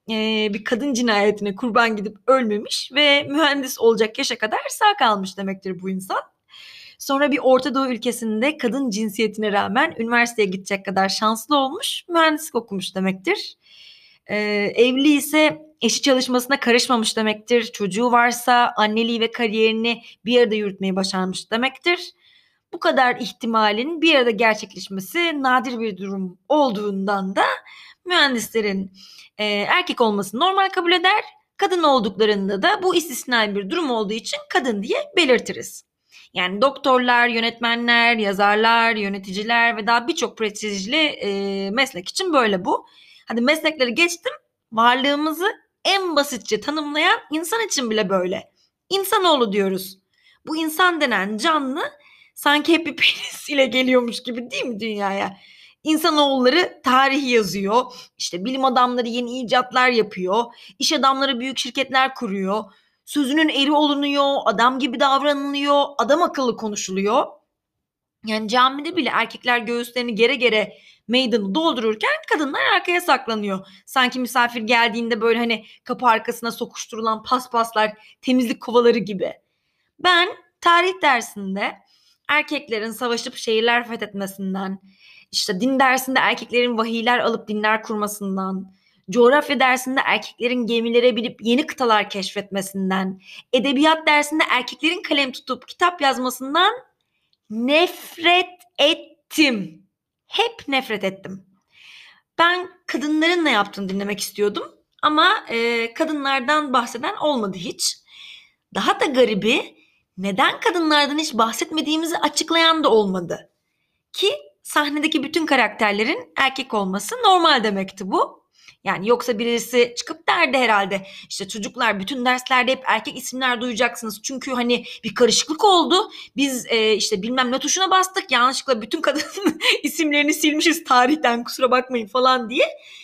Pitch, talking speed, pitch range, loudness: 245 Hz, 120 wpm, 215-290 Hz, -19 LUFS